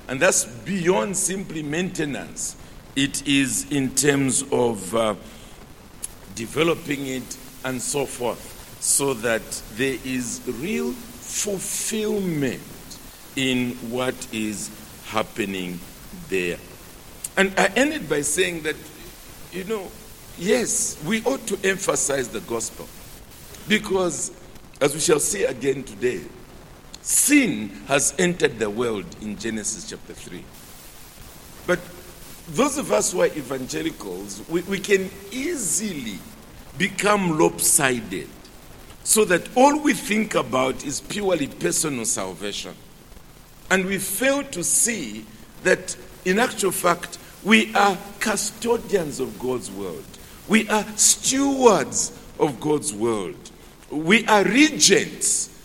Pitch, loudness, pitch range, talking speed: 170 Hz, -22 LUFS, 130-210 Hz, 115 wpm